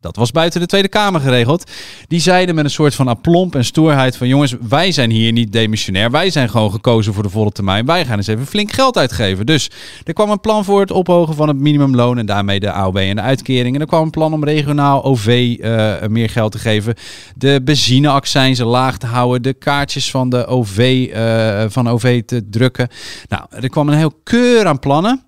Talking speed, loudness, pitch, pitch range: 220 wpm, -14 LUFS, 130 Hz, 115-155 Hz